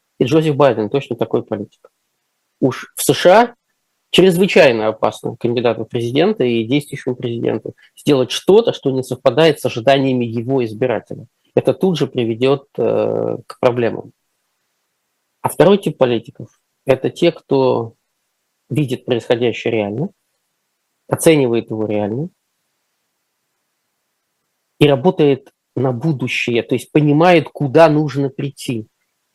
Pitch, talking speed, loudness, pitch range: 135 Hz, 110 wpm, -16 LUFS, 120-155 Hz